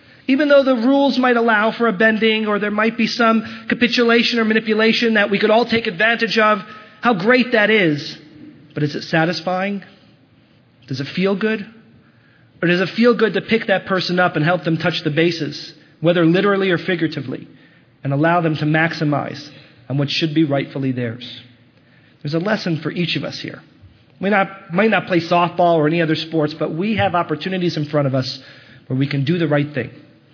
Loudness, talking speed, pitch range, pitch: -17 LUFS, 195 wpm, 150-215 Hz, 175 Hz